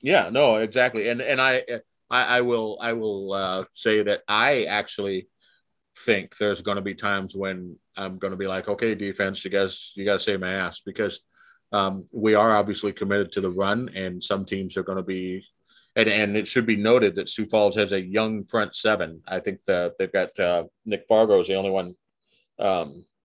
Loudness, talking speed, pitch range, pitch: -24 LUFS, 210 wpm, 95-110 Hz, 100 Hz